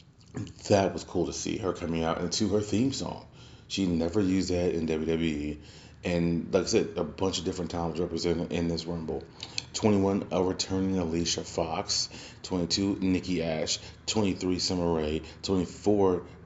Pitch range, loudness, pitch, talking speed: 85-95 Hz, -29 LUFS, 90 Hz, 155 wpm